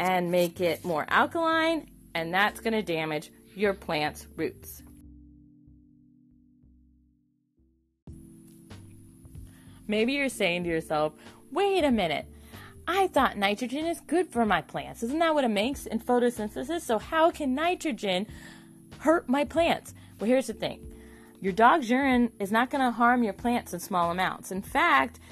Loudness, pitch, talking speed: -27 LUFS, 200 Hz, 140 wpm